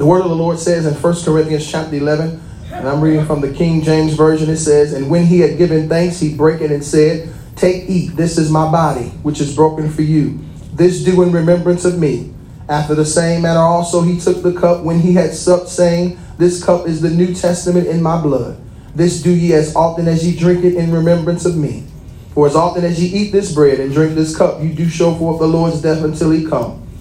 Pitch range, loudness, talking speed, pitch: 155-175 Hz, -14 LUFS, 240 wpm, 165 Hz